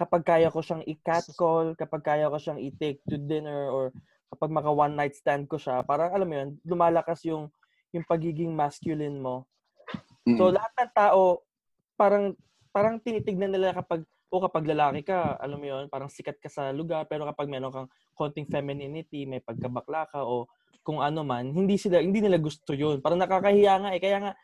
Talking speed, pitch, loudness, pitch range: 185 wpm, 155 Hz, -27 LUFS, 145-180 Hz